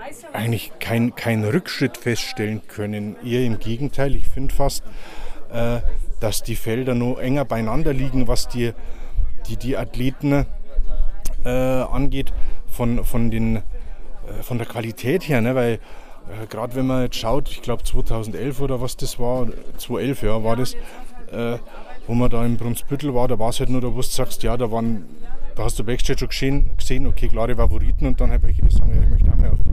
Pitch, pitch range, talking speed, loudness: 120 Hz, 110-130 Hz, 180 wpm, -23 LUFS